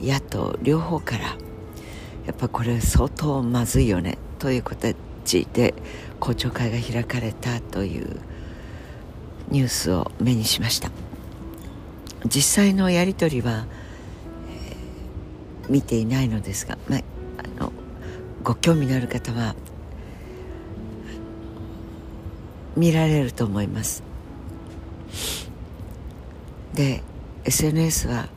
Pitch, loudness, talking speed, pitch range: 110 Hz, -23 LUFS, 175 characters per minute, 85-125 Hz